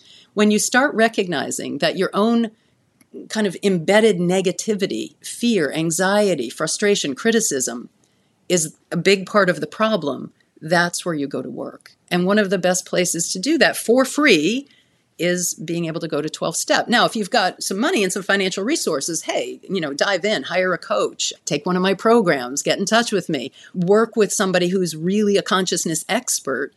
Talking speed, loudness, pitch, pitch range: 185 wpm, -19 LUFS, 190 Hz, 170-215 Hz